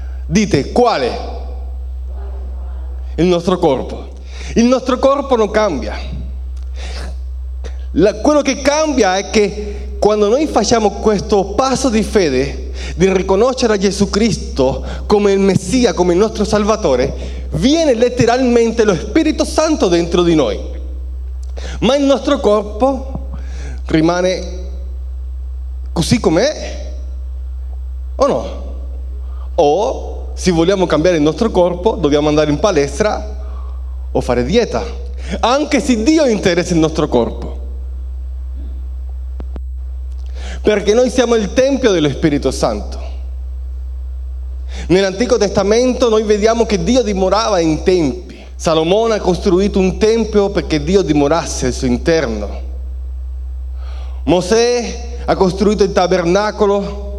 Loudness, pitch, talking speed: -14 LUFS, 155 Hz, 110 wpm